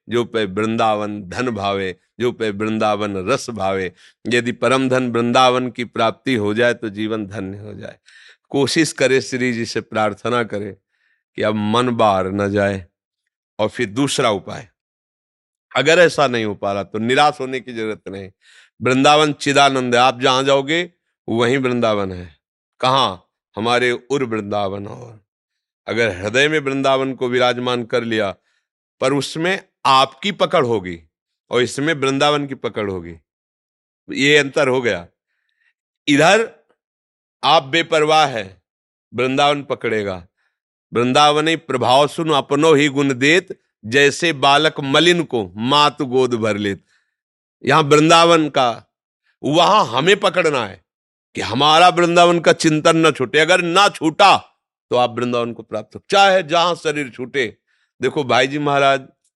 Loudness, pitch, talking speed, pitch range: -16 LUFS, 125 Hz, 145 wpm, 110-145 Hz